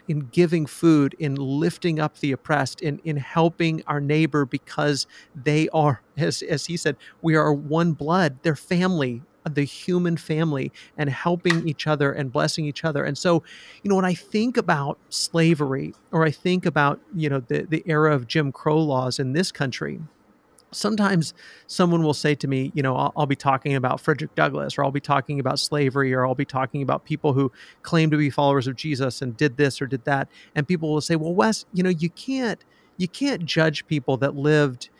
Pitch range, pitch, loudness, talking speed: 140-165 Hz, 150 Hz, -23 LUFS, 200 wpm